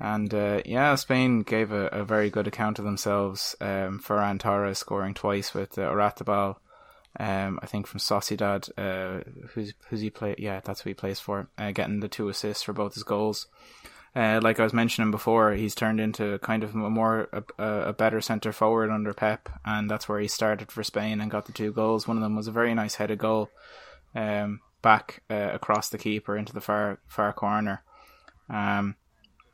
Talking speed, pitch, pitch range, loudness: 200 wpm, 105 Hz, 100-110 Hz, -28 LUFS